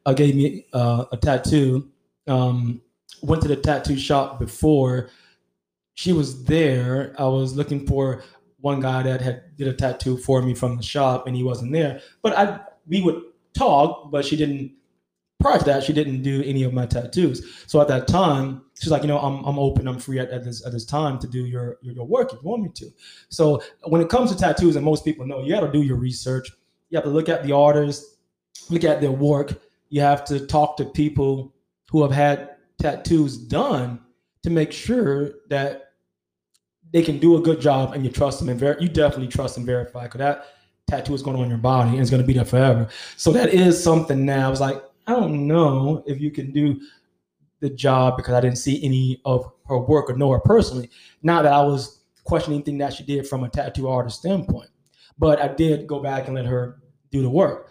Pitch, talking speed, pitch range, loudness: 140 Hz, 220 wpm, 125-150 Hz, -21 LUFS